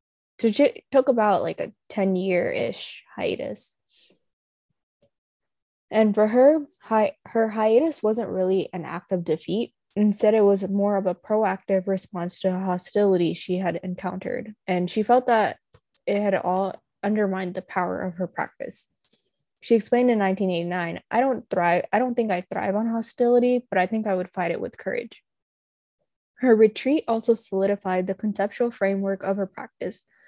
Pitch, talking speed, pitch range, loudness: 200 Hz, 160 wpm, 185-225 Hz, -24 LUFS